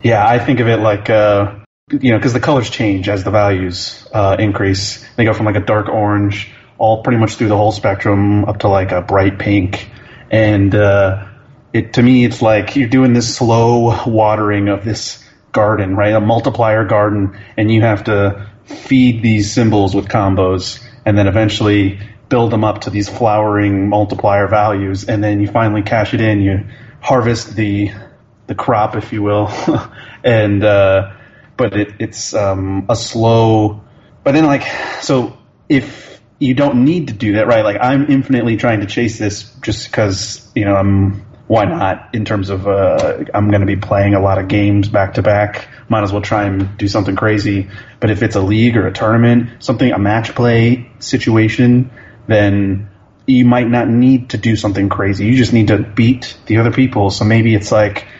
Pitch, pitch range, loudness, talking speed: 110 Hz, 100-120 Hz, -13 LUFS, 190 wpm